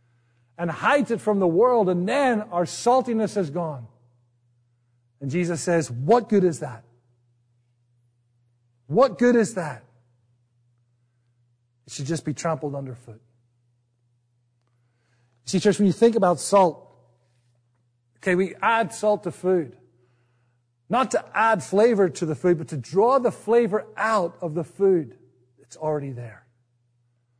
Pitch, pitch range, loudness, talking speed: 130 Hz, 120-185 Hz, -22 LUFS, 135 wpm